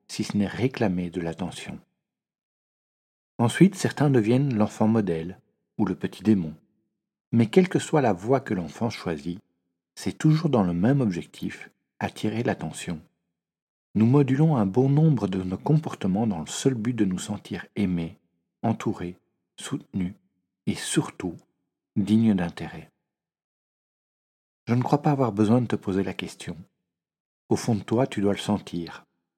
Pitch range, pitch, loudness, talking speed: 90-125 Hz, 105 Hz, -25 LUFS, 150 wpm